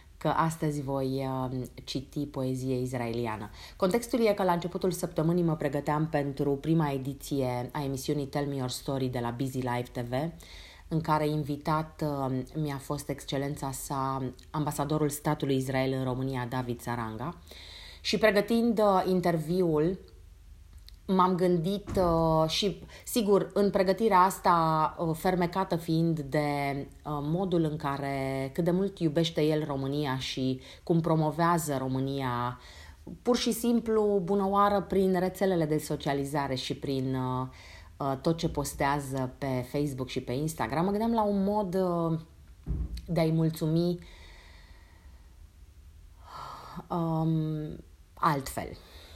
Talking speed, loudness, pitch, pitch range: 120 wpm, -29 LUFS, 150 Hz, 130-175 Hz